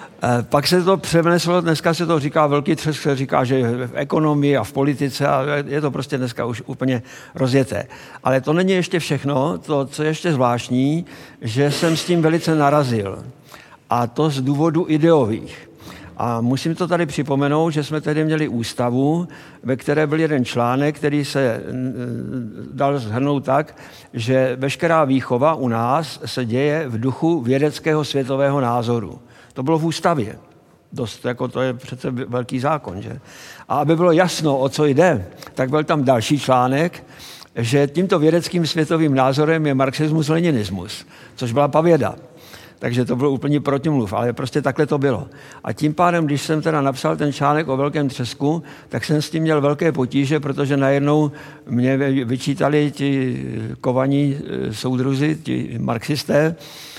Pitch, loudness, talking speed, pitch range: 140 Hz, -19 LUFS, 160 wpm, 130-155 Hz